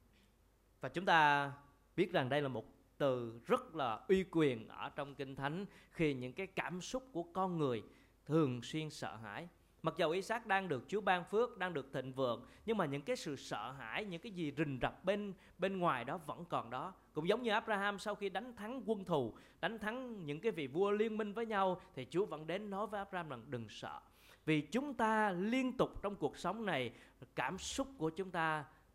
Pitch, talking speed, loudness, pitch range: 180 Hz, 220 wpm, -39 LUFS, 145-205 Hz